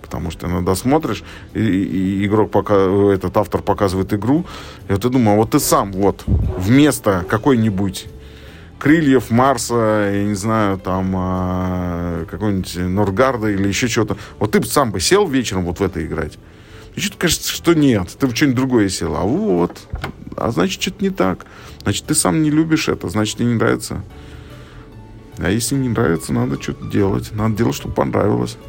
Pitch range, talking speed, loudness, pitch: 95-120 Hz, 175 wpm, -17 LUFS, 105 Hz